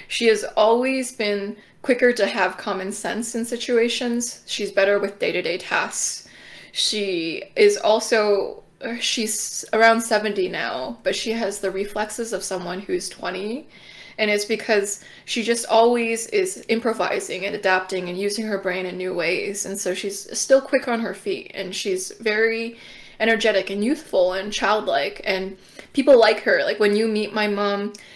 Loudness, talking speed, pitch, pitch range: -22 LUFS, 160 wpm, 215 Hz, 195-230 Hz